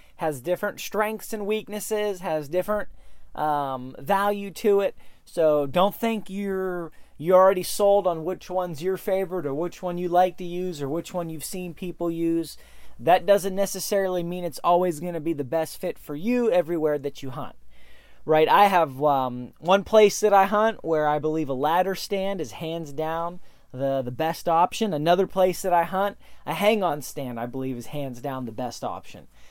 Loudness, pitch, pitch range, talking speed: -24 LUFS, 175 Hz, 150-195 Hz, 190 wpm